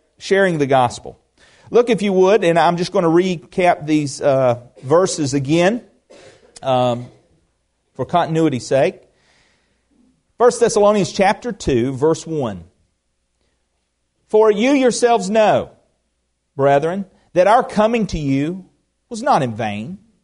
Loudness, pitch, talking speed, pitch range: -17 LUFS, 165 Hz, 120 wpm, 125-205 Hz